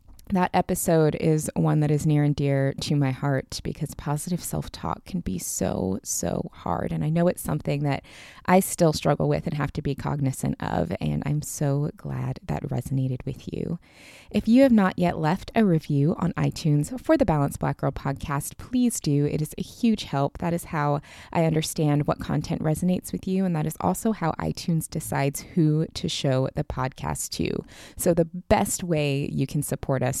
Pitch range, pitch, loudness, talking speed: 140-175 Hz, 150 Hz, -25 LUFS, 195 wpm